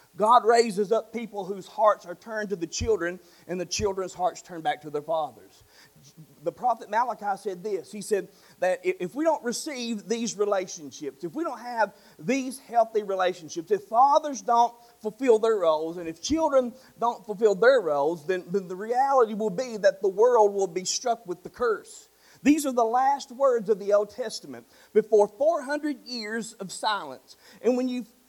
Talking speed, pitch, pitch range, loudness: 180 wpm, 220 Hz, 190-260 Hz, -26 LUFS